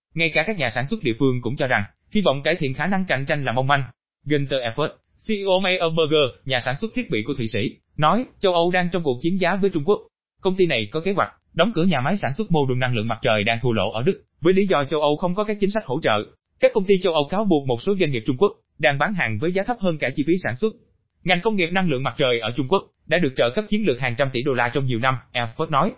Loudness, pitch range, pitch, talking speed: -22 LUFS, 130-195 Hz, 155 Hz, 305 wpm